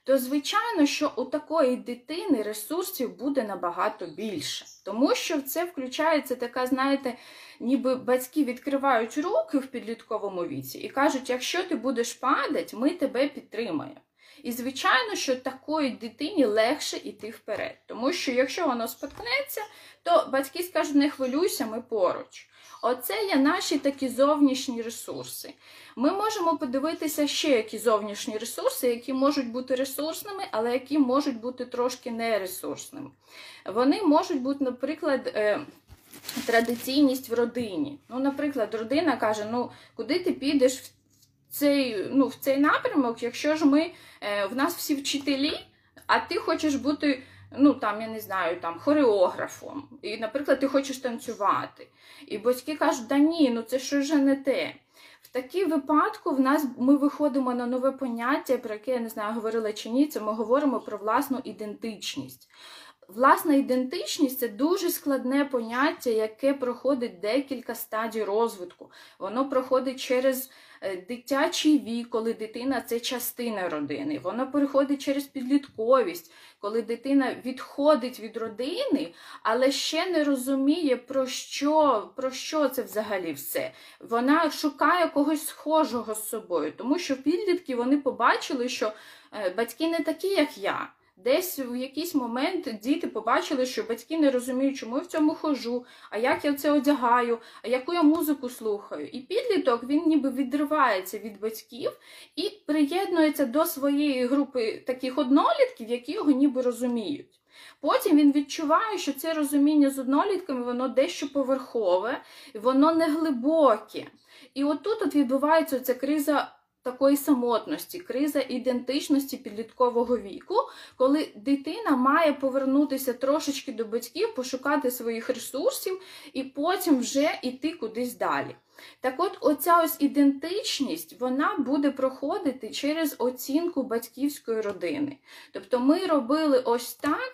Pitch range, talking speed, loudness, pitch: 245-305 Hz, 135 wpm, -26 LUFS, 275 Hz